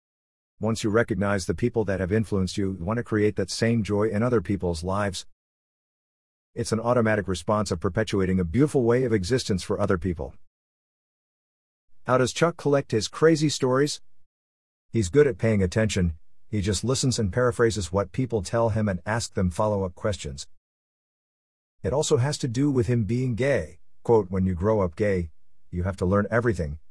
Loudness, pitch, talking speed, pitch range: -25 LUFS, 105 Hz, 180 wpm, 95-115 Hz